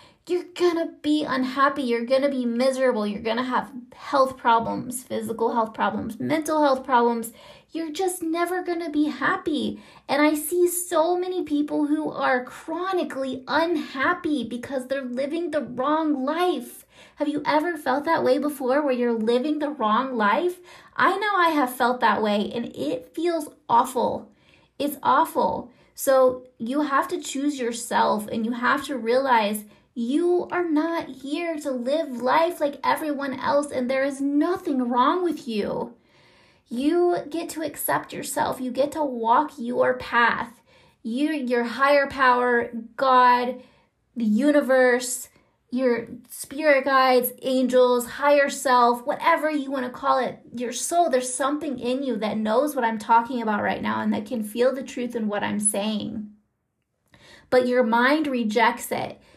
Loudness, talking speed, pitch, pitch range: -23 LUFS, 155 wpm, 265 Hz, 245-300 Hz